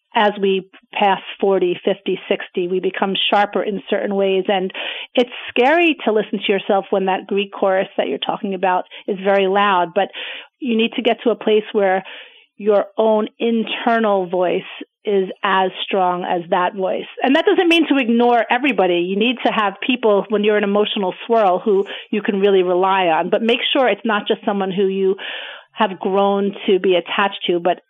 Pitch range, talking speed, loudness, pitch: 190-225 Hz, 190 wpm, -18 LUFS, 205 Hz